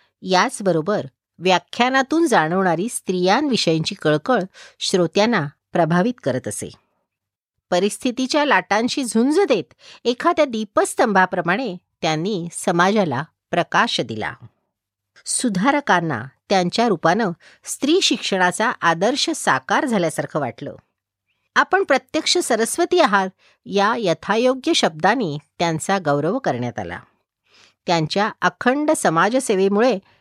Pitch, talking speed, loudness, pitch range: 195 Hz, 85 wpm, -19 LUFS, 170-250 Hz